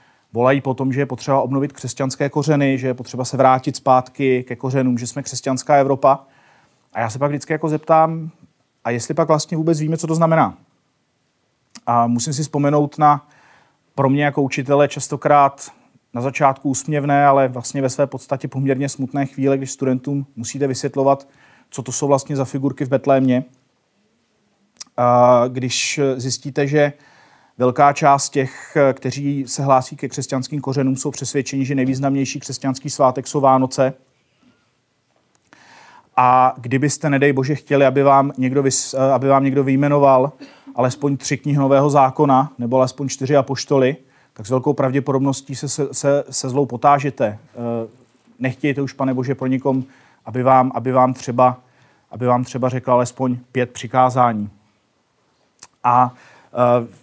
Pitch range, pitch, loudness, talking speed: 130-140 Hz, 135 Hz, -18 LUFS, 145 wpm